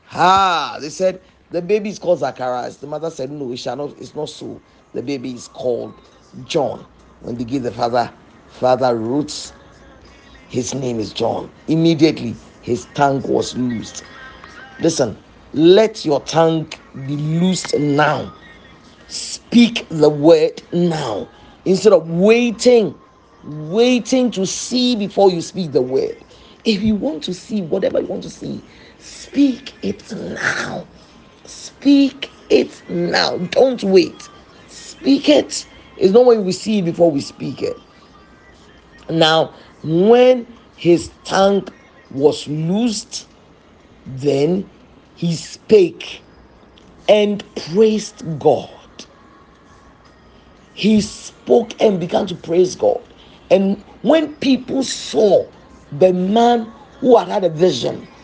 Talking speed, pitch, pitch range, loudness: 125 wpm, 180 Hz, 150-230 Hz, -17 LUFS